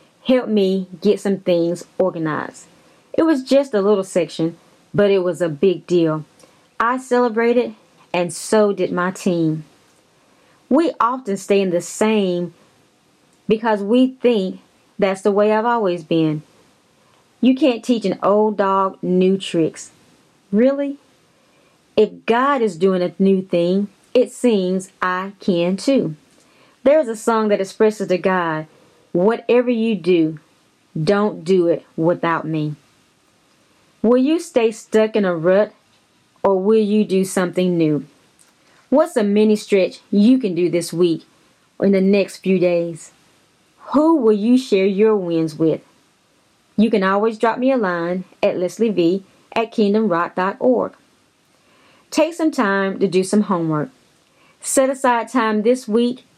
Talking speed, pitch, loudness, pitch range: 145 wpm, 195 Hz, -18 LUFS, 175-230 Hz